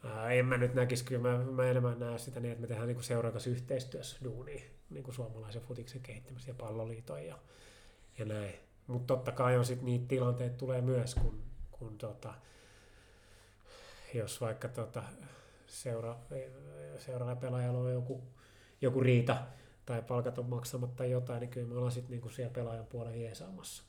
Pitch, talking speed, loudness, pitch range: 125 Hz, 160 wpm, -37 LUFS, 115-125 Hz